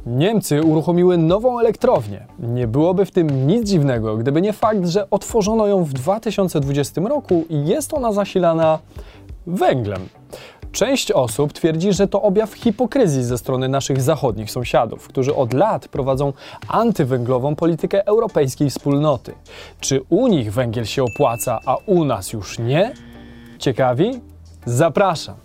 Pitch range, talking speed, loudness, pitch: 130-200 Hz, 135 wpm, -18 LUFS, 155 Hz